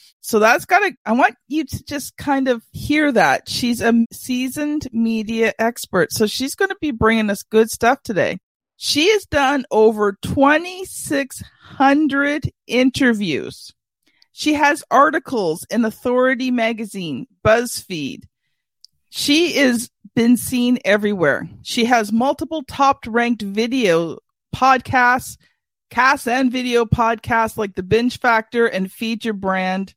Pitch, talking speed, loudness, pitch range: 245 Hz, 130 wpm, -18 LUFS, 225-275 Hz